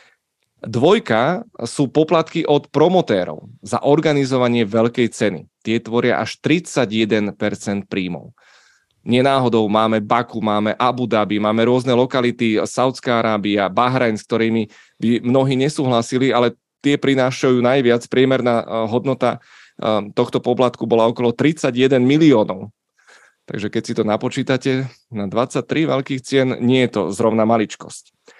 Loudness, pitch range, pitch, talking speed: -18 LUFS, 110-130 Hz, 120 Hz, 120 wpm